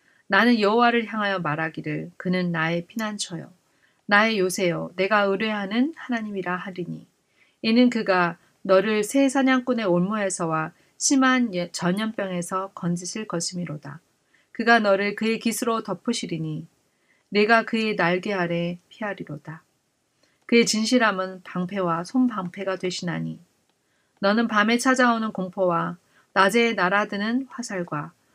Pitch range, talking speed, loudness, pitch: 175-225 Hz, 285 characters per minute, -23 LUFS, 195 Hz